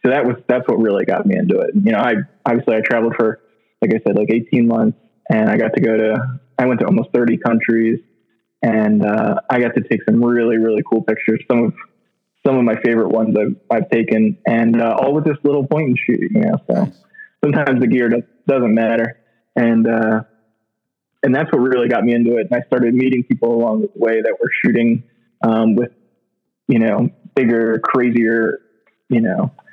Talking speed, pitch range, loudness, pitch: 210 wpm, 115-125 Hz, -16 LUFS, 115 Hz